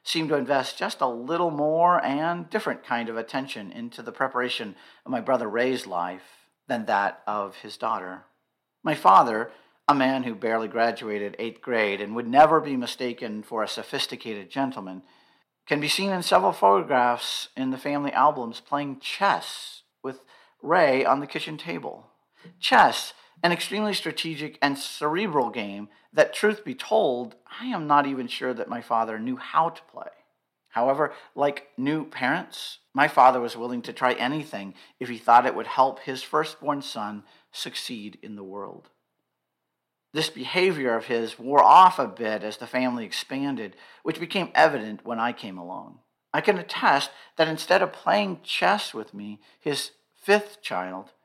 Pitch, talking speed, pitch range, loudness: 130 Hz, 165 wpm, 115-155 Hz, -24 LUFS